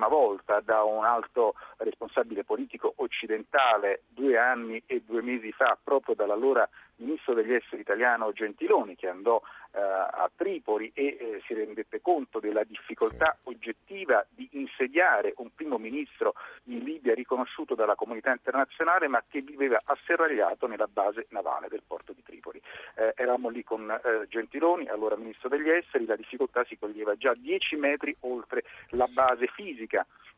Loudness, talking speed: -28 LUFS, 150 wpm